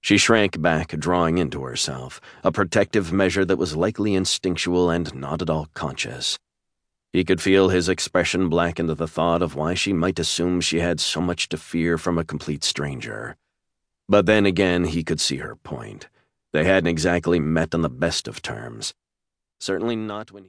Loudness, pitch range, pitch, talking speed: -22 LUFS, 80-95 Hz, 85 Hz, 185 wpm